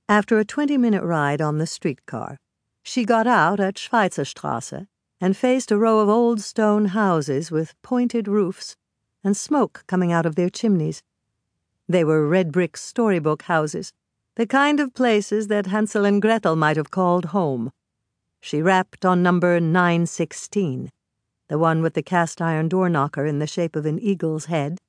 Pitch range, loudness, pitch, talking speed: 155-210 Hz, -21 LUFS, 180 Hz, 165 wpm